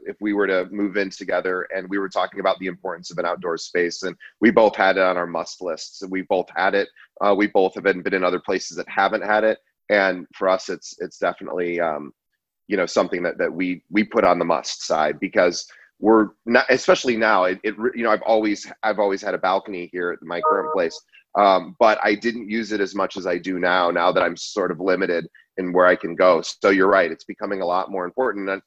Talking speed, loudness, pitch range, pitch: 245 wpm, -21 LUFS, 90-110 Hz, 95 Hz